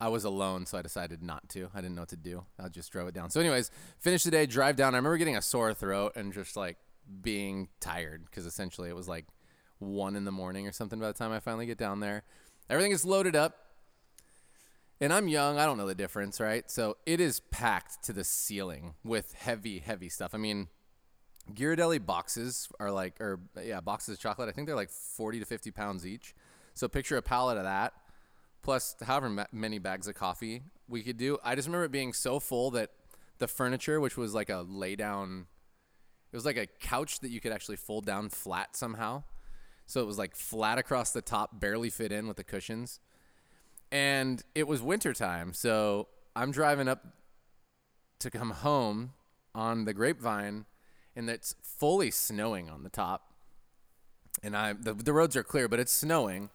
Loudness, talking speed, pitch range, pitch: -33 LUFS, 200 wpm, 95-125 Hz, 110 Hz